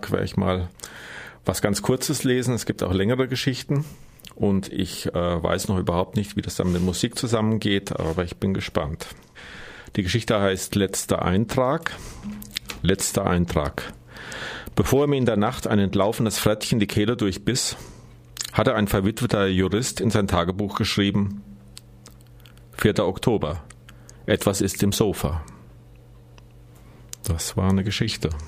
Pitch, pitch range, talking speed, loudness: 100 Hz, 90-110 Hz, 140 wpm, -23 LUFS